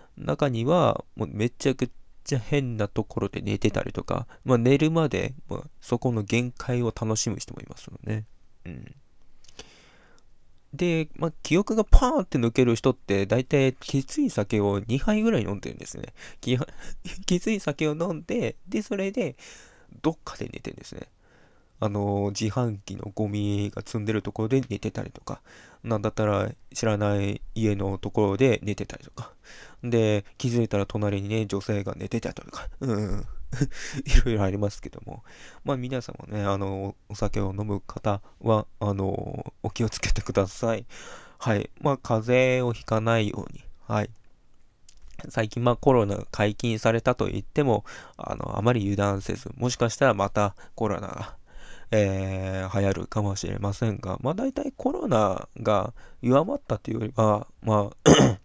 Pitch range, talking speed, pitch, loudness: 100-130 Hz, 310 characters per minute, 110 Hz, -26 LUFS